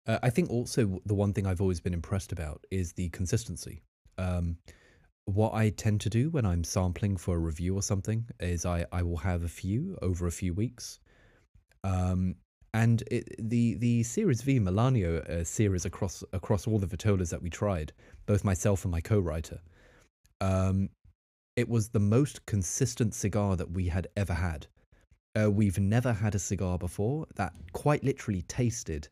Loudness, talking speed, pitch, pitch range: -30 LUFS, 175 wpm, 100 Hz, 90-110 Hz